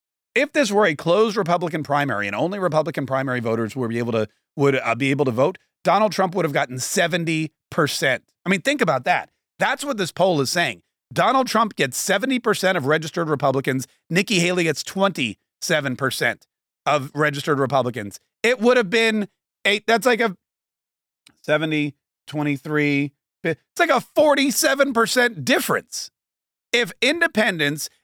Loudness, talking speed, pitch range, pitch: -21 LUFS, 150 wpm, 140-215 Hz, 170 Hz